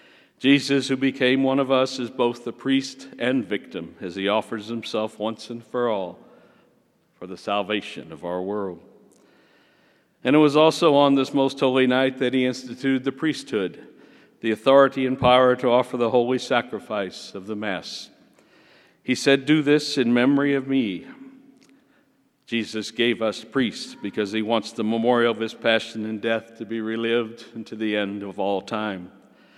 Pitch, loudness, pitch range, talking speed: 120 Hz, -22 LUFS, 110-135 Hz, 170 wpm